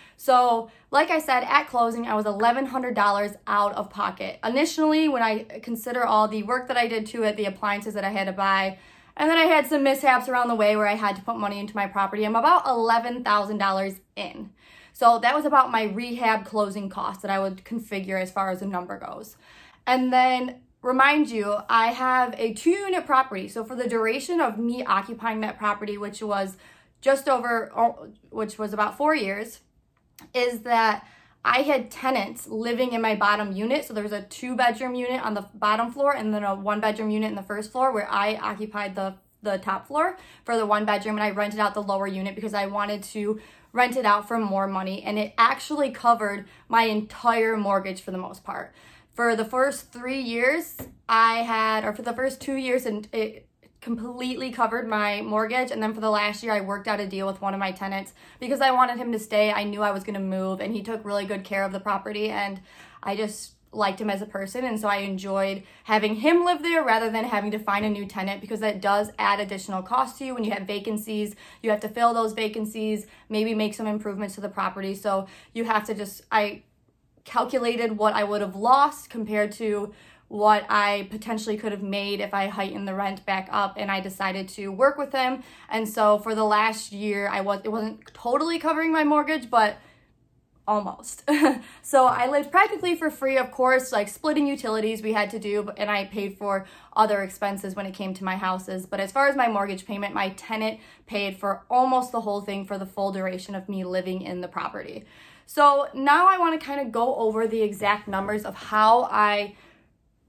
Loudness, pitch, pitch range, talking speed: -25 LUFS, 215 Hz, 200-245 Hz, 210 wpm